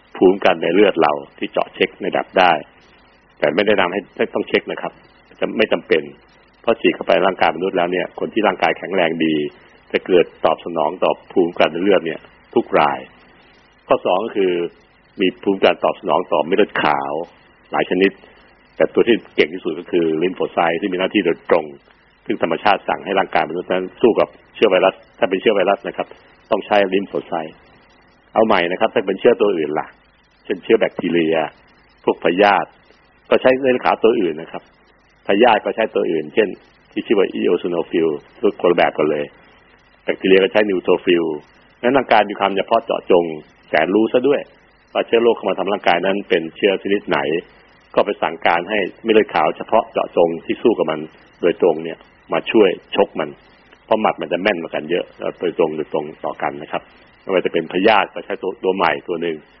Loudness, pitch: -18 LUFS, 95 Hz